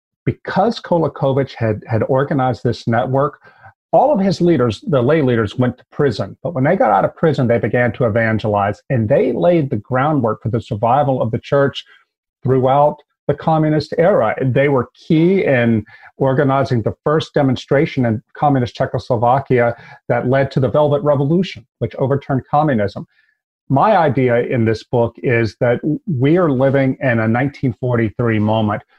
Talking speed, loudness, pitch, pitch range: 160 wpm, -16 LUFS, 130 Hz, 120-145 Hz